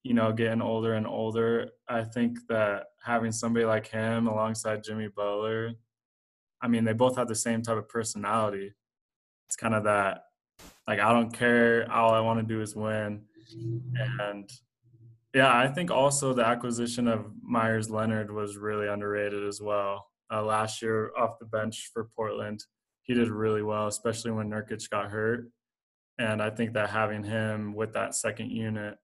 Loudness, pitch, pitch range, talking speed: -29 LUFS, 110 Hz, 105-115 Hz, 170 wpm